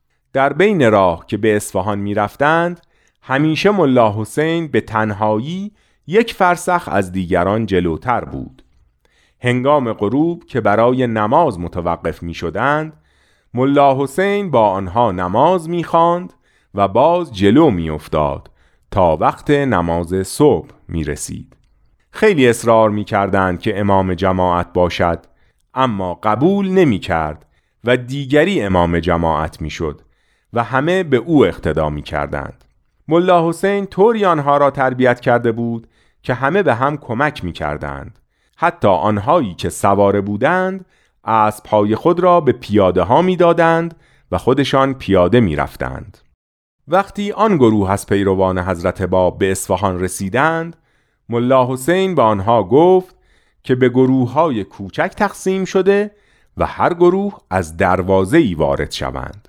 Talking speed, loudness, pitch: 135 wpm, -16 LUFS, 115 Hz